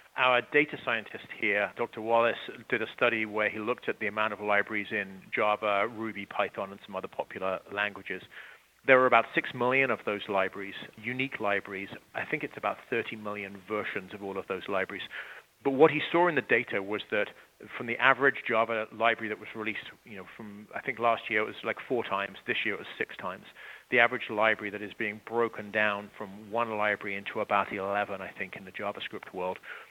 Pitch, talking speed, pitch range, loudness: 110 Hz, 205 wpm, 105-120 Hz, -30 LUFS